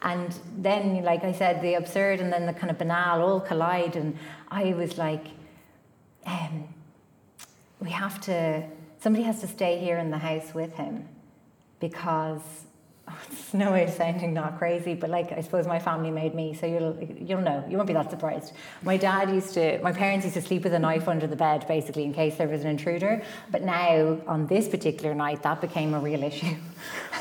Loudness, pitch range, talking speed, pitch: -27 LUFS, 160-180 Hz, 205 wpm, 170 Hz